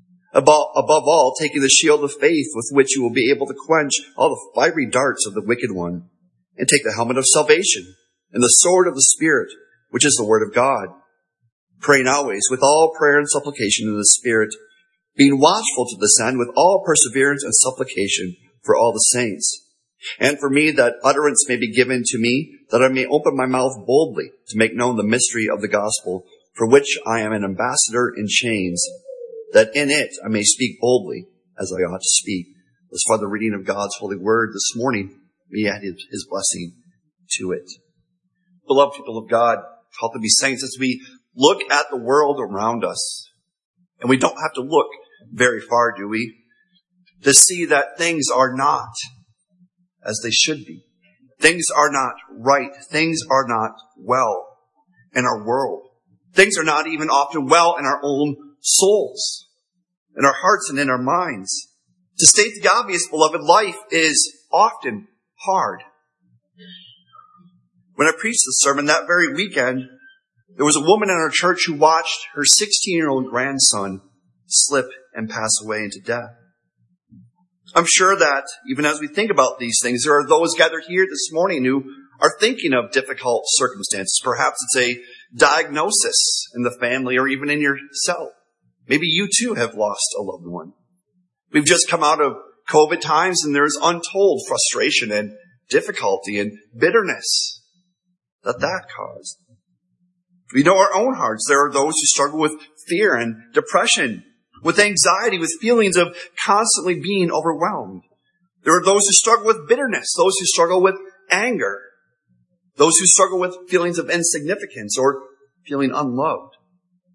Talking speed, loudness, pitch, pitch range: 170 wpm, -17 LUFS, 140 Hz, 115-180 Hz